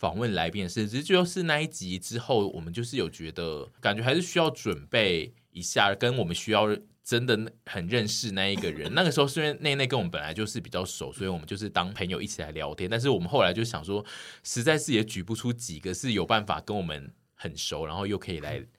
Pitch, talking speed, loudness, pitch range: 110 Hz, 350 characters per minute, -28 LUFS, 95-130 Hz